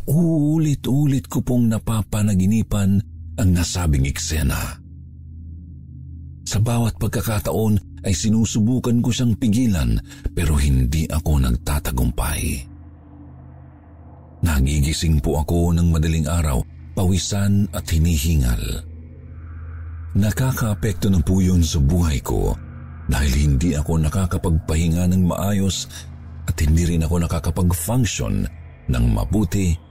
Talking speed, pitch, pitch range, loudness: 100 wpm, 85 Hz, 75-100 Hz, -20 LUFS